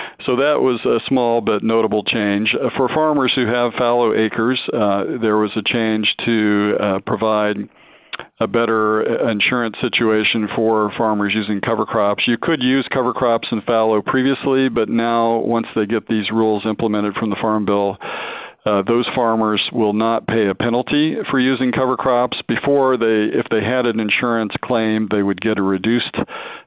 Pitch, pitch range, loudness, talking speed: 115 Hz, 105-120 Hz, -17 LUFS, 170 wpm